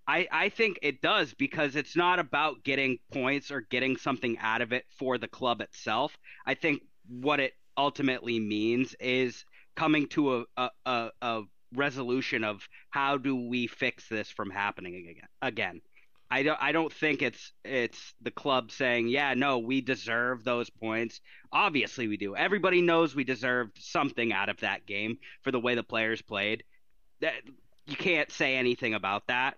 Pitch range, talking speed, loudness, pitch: 115-140 Hz, 170 wpm, -30 LUFS, 125 Hz